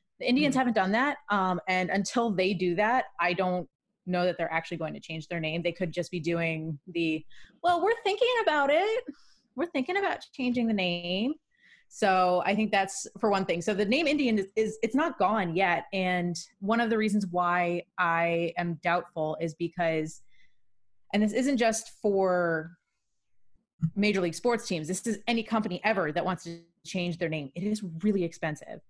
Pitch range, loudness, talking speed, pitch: 170-230 Hz, -28 LUFS, 190 wpm, 185 Hz